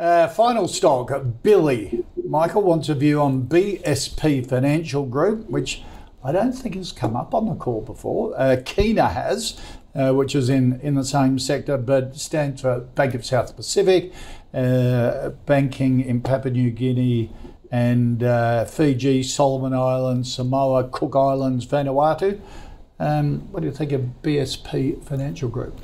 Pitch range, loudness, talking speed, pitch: 125-150 Hz, -21 LUFS, 150 wpm, 135 Hz